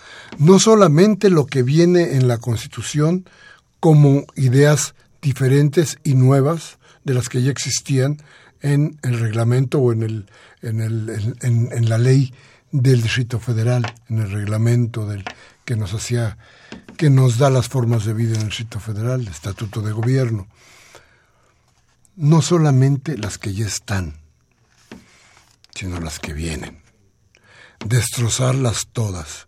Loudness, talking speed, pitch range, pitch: -18 LUFS, 140 wpm, 110-140 Hz, 120 Hz